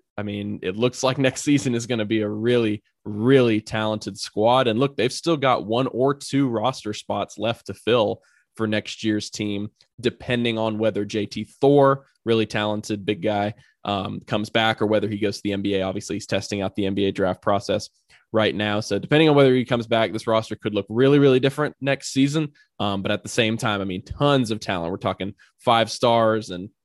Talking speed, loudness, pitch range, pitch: 210 wpm, -22 LUFS, 105-125 Hz, 110 Hz